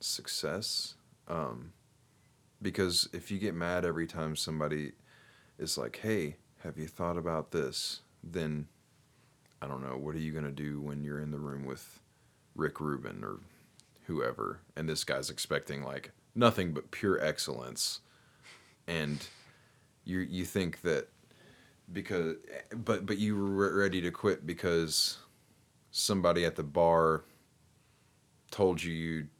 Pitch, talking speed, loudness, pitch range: 85 Hz, 135 wpm, -34 LUFS, 75-100 Hz